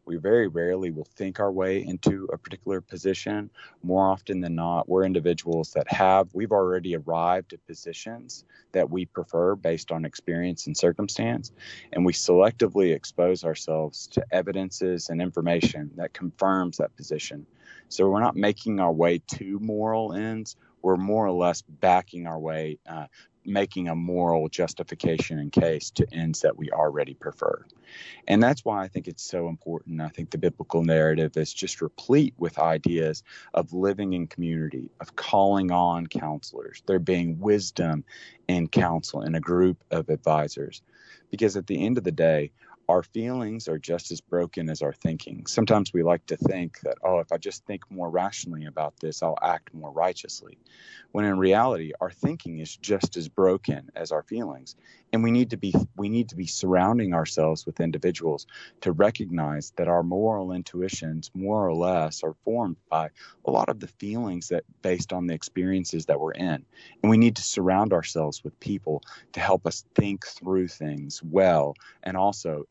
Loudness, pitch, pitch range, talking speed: -26 LUFS, 90 Hz, 80-95 Hz, 175 wpm